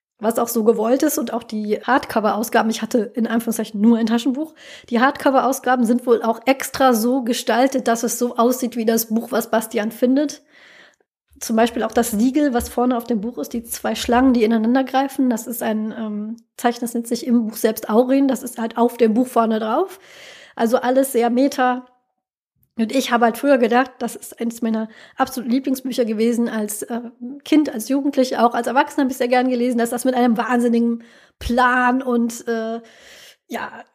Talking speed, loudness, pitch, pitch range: 195 wpm, -19 LUFS, 240 Hz, 230-255 Hz